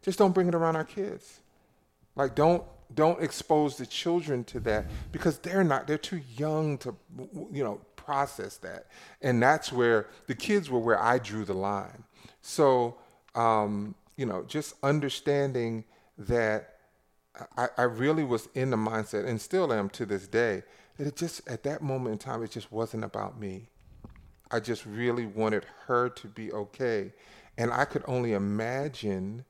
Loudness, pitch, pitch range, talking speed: -30 LUFS, 120 Hz, 110-150 Hz, 170 wpm